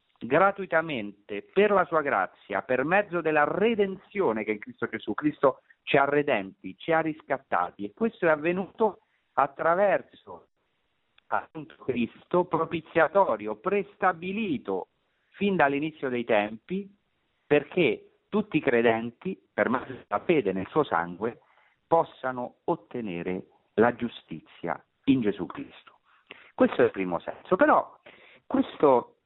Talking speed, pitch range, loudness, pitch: 120 wpm, 115-185 Hz, -27 LUFS, 150 Hz